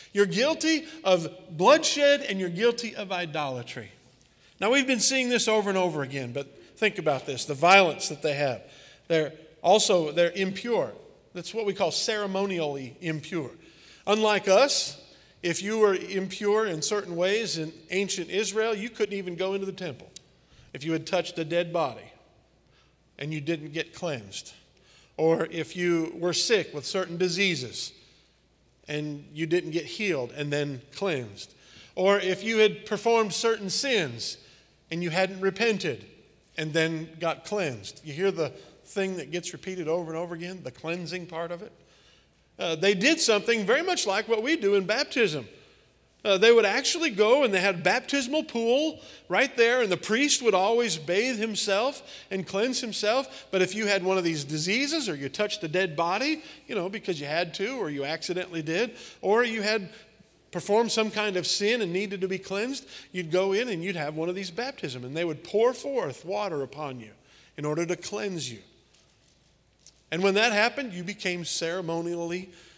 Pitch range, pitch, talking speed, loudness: 165-215 Hz, 185 Hz, 180 wpm, -26 LUFS